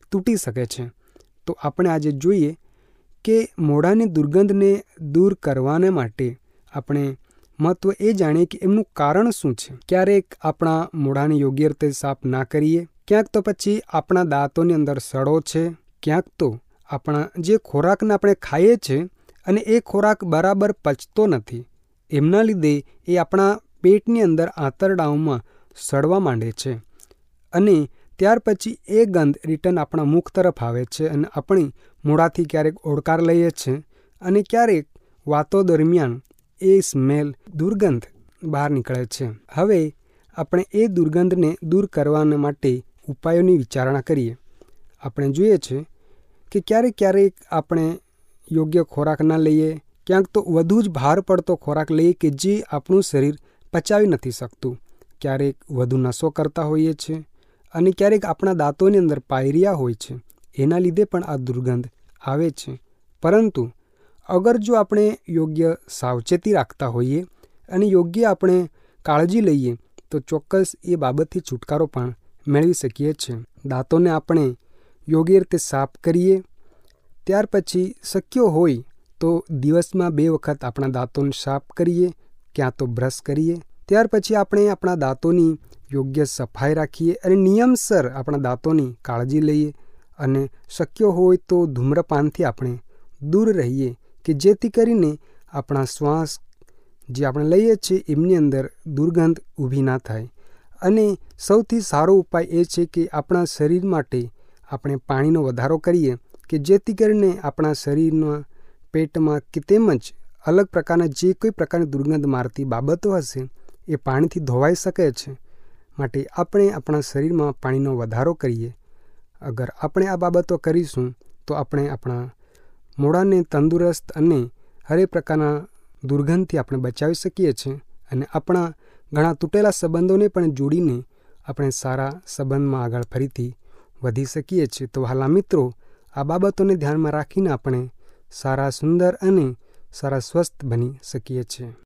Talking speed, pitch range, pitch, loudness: 135 wpm, 135-185 Hz, 155 Hz, -20 LUFS